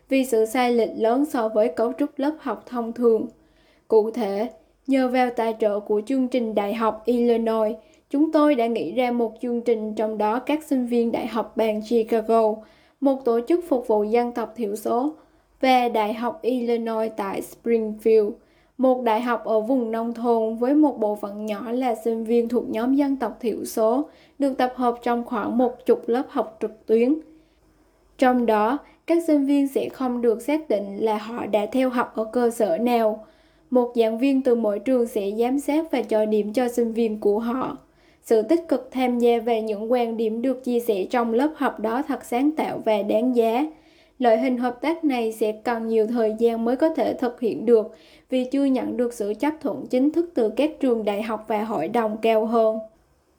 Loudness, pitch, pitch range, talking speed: -23 LUFS, 235 Hz, 220-260 Hz, 205 wpm